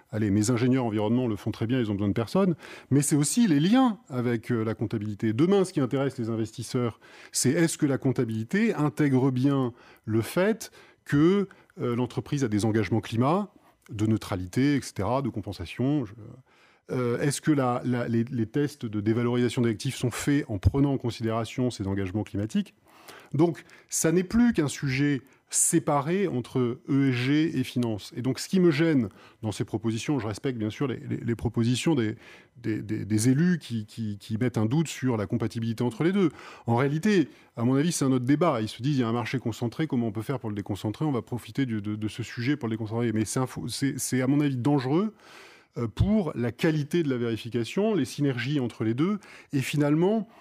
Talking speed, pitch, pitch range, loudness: 200 wpm, 125 Hz, 115-150 Hz, -27 LUFS